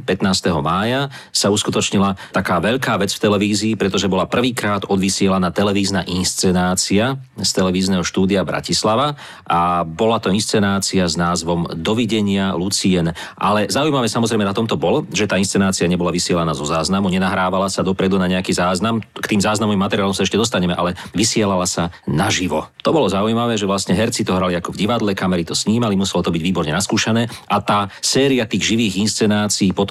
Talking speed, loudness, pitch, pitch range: 165 wpm, -17 LUFS, 100 Hz, 90-110 Hz